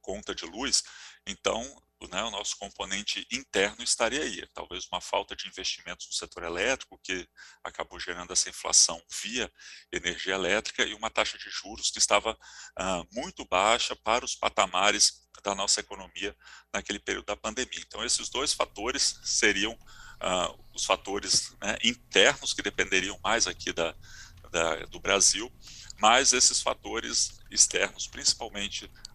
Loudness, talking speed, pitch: -27 LUFS, 145 wpm, 110 Hz